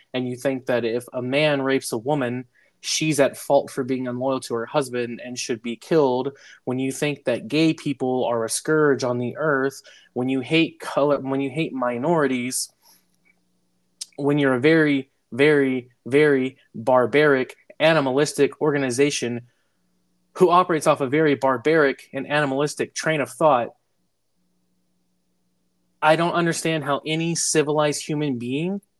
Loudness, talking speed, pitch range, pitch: -22 LUFS, 145 wpm, 125-150 Hz, 135 Hz